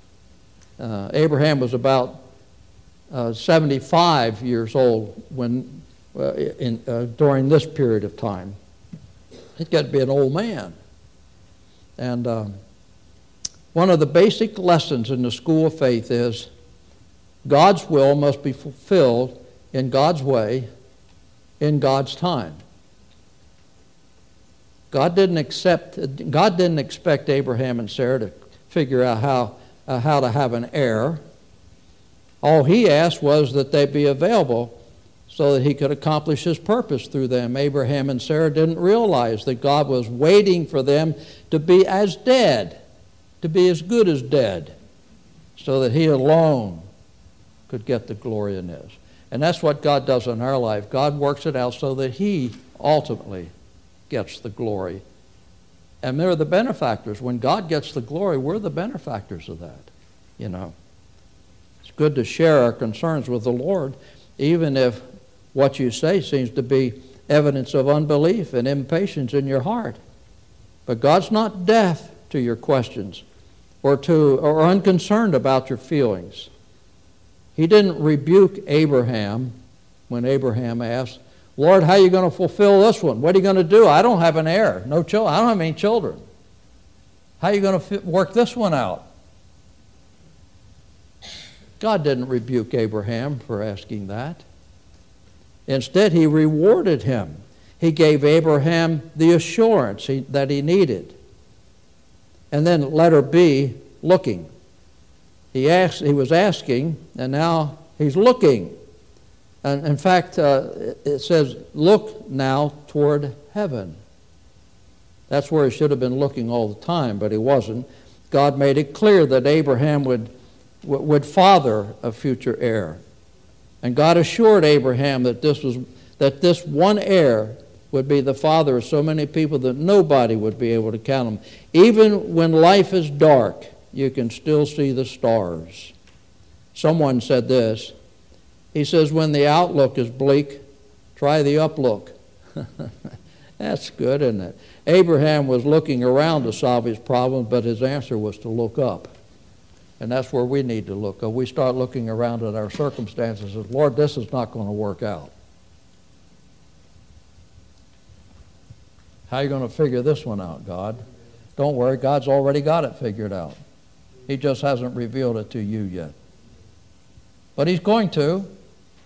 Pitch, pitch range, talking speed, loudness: 135 Hz, 110-155 Hz, 150 wpm, -19 LUFS